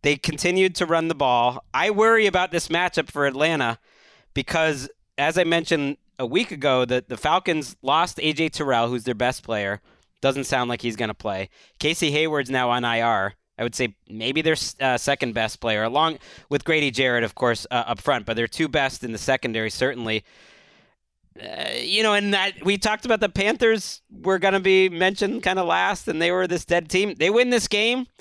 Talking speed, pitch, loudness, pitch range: 205 wpm, 150 Hz, -22 LUFS, 125-185 Hz